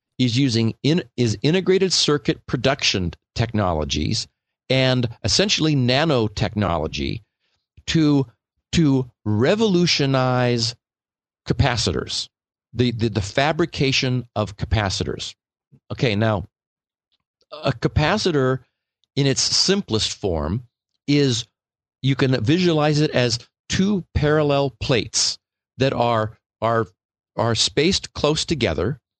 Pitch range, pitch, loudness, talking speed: 110-145 Hz, 125 Hz, -20 LUFS, 90 wpm